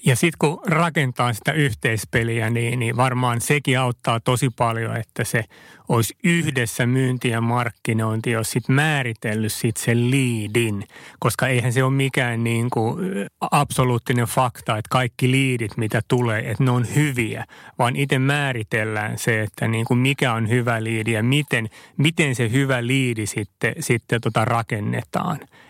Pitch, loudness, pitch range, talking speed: 120 Hz, -21 LUFS, 115-130 Hz, 150 wpm